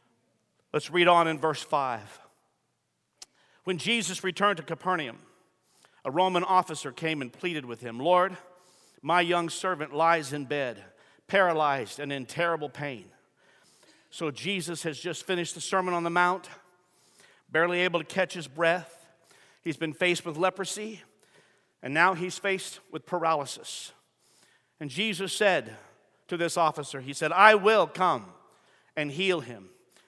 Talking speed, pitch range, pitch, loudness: 145 wpm, 155-185 Hz, 170 Hz, -27 LUFS